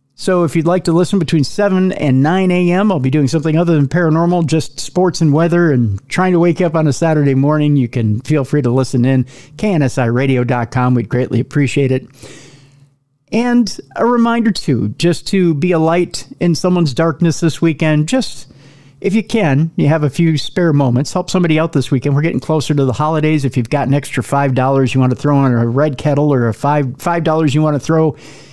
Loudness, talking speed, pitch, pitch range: -14 LUFS, 210 wpm, 150 Hz, 135-170 Hz